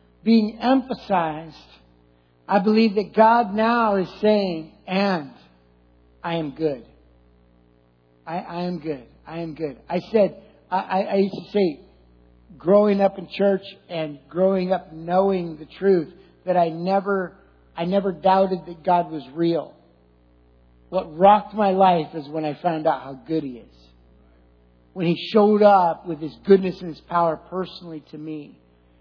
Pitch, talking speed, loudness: 170 Hz, 150 wpm, -21 LUFS